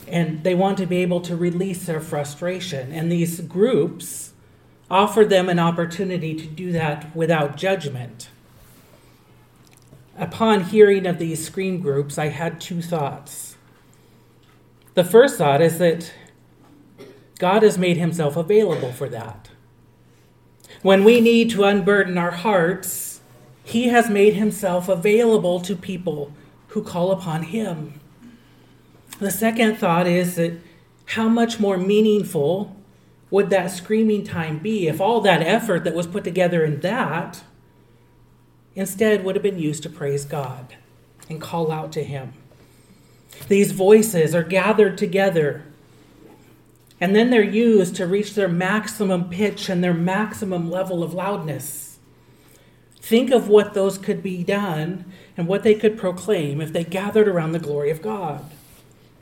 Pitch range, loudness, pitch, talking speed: 160-205 Hz, -20 LUFS, 180 Hz, 140 wpm